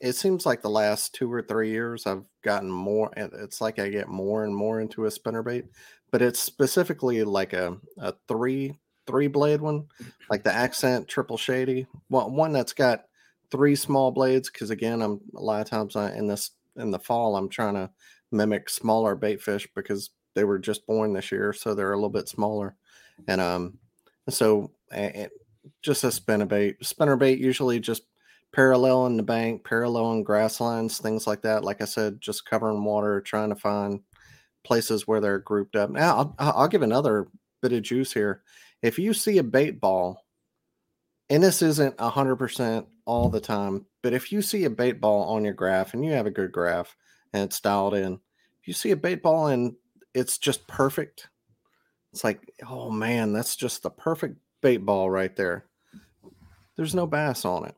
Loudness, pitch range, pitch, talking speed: -26 LUFS, 105-130 Hz, 110 Hz, 190 wpm